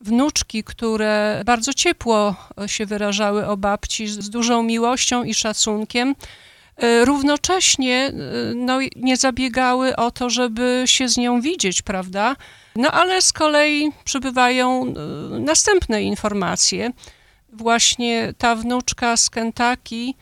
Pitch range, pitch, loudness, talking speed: 220-260 Hz, 240 Hz, -18 LUFS, 110 wpm